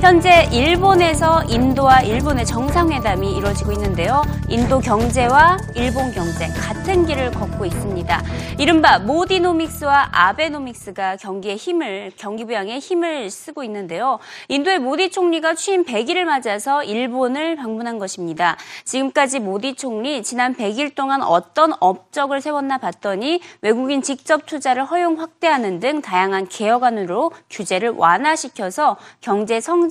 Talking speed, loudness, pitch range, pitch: 325 characters per minute, -18 LUFS, 210-325 Hz, 275 Hz